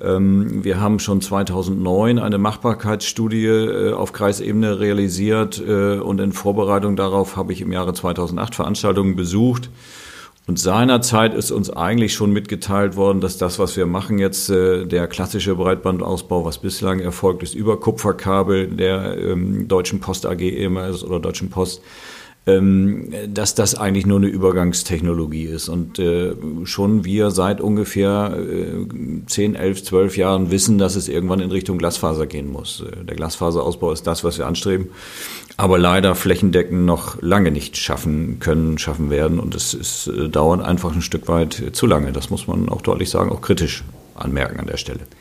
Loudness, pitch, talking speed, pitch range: -19 LUFS, 95 Hz, 150 wpm, 90-100 Hz